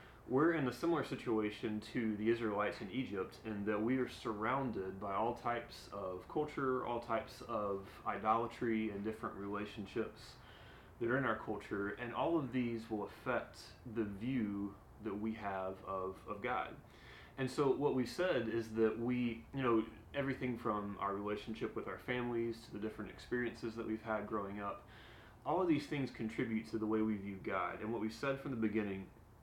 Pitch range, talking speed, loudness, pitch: 105-120 Hz, 185 wpm, -39 LUFS, 110 Hz